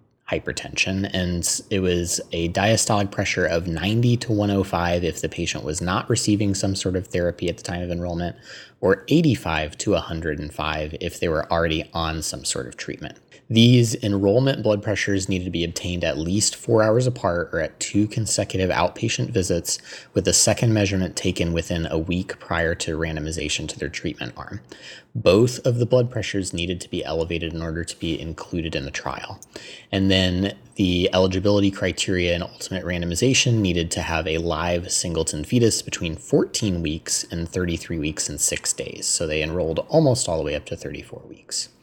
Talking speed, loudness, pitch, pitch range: 180 wpm, -22 LUFS, 90 Hz, 85-105 Hz